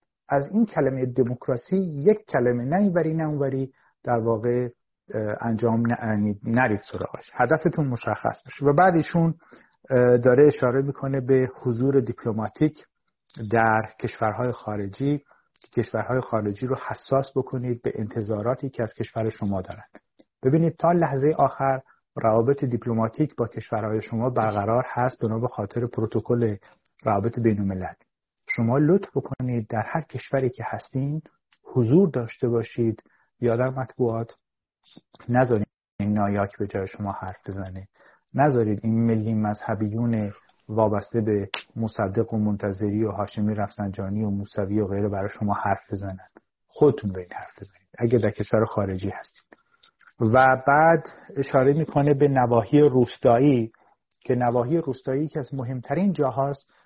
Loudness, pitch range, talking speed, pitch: -24 LUFS, 110-135 Hz, 130 wpm, 120 Hz